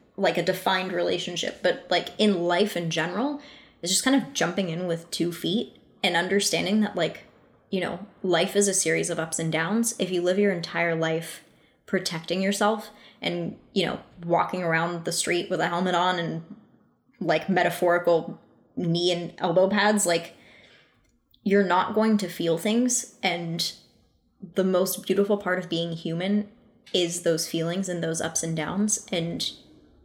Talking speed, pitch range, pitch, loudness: 165 wpm, 170-200 Hz, 180 Hz, -25 LUFS